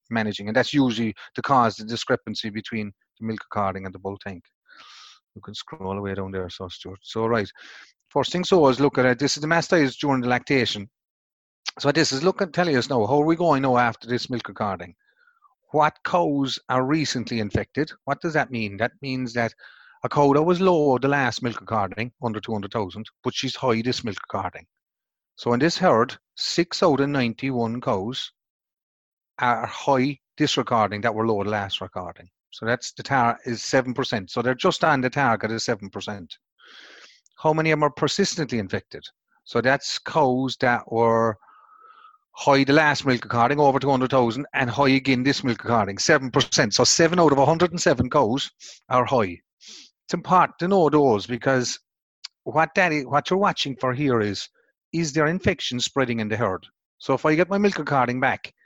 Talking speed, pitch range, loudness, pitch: 190 wpm, 115-150 Hz, -22 LUFS, 130 Hz